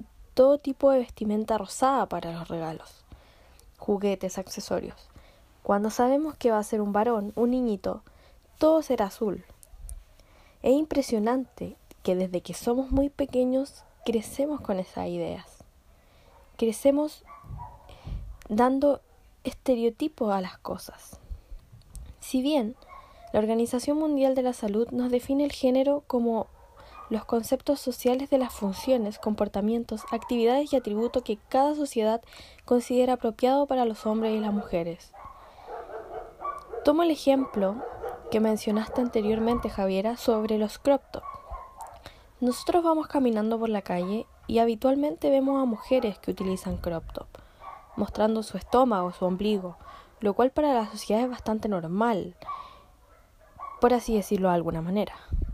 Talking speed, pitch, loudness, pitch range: 130 wpm, 235 Hz, -27 LUFS, 210-265 Hz